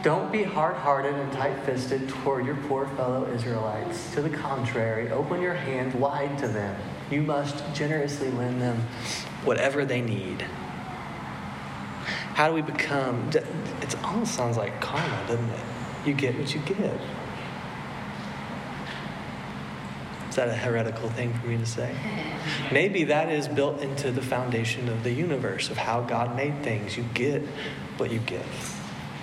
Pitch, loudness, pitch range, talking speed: 125 Hz, -28 LUFS, 115-145 Hz, 150 wpm